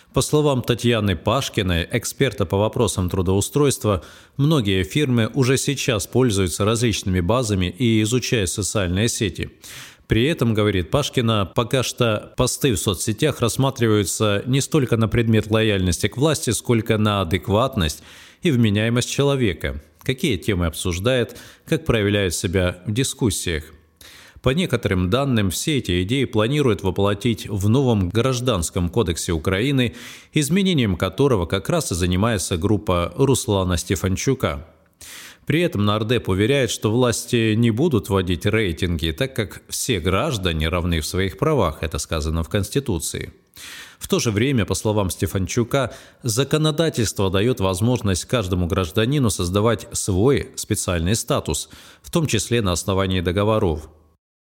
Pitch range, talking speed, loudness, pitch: 95-125 Hz, 130 wpm, -20 LUFS, 110 Hz